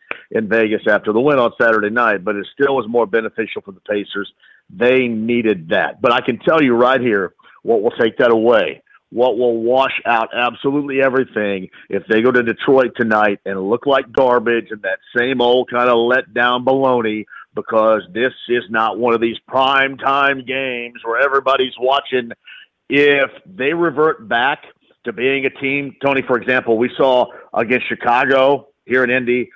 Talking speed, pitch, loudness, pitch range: 180 wpm, 125 Hz, -16 LUFS, 115-135 Hz